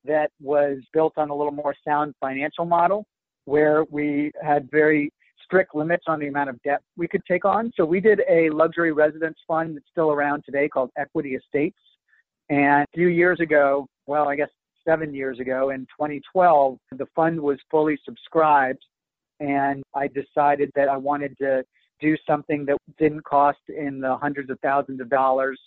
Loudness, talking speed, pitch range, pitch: -22 LUFS, 180 wpm, 140-160 Hz, 145 Hz